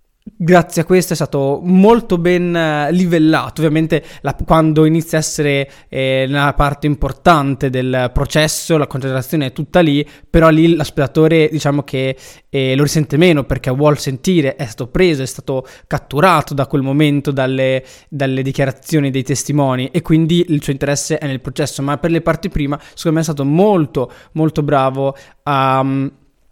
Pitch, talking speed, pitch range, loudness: 145 Hz, 165 wpm, 135-160 Hz, -15 LUFS